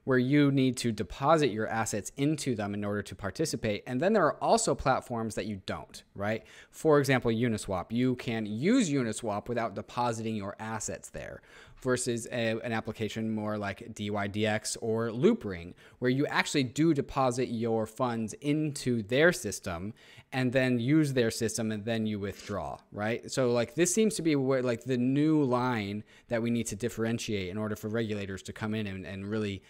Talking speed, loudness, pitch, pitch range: 180 wpm, -30 LUFS, 115 Hz, 105-130 Hz